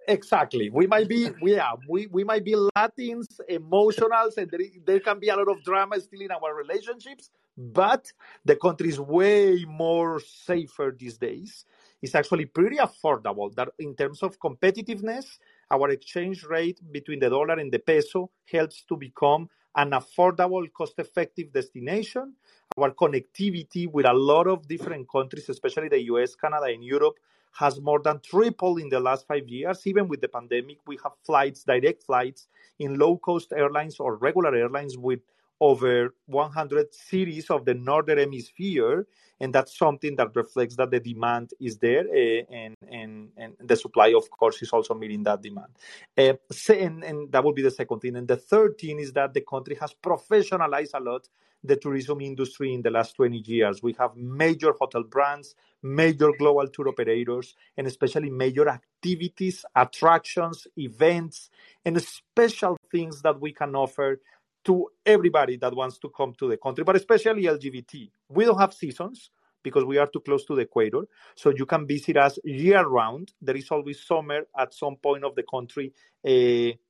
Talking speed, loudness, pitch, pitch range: 175 wpm, -25 LUFS, 155 Hz, 135-195 Hz